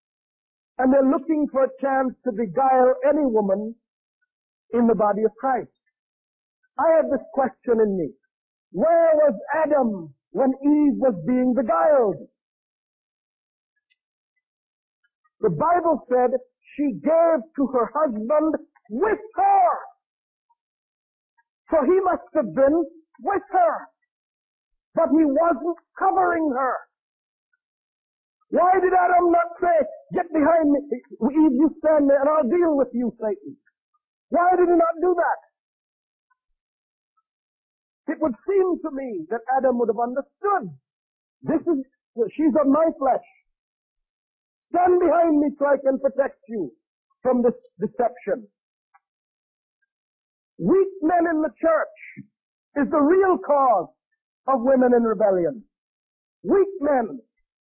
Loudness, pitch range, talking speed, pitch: -21 LUFS, 255-345 Hz, 120 wpm, 295 Hz